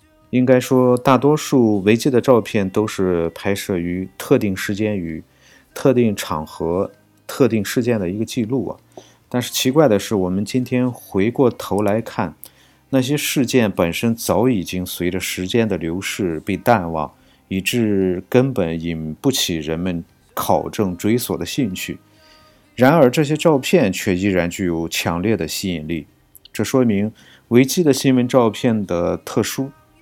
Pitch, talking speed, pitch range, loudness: 105 Hz, 230 characters per minute, 90-125 Hz, -18 LUFS